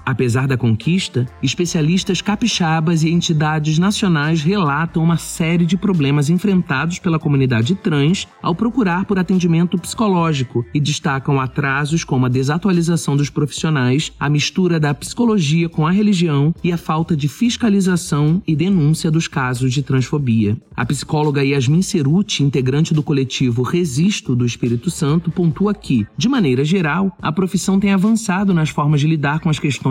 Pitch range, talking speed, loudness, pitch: 140-180 Hz, 150 wpm, -17 LUFS, 160 Hz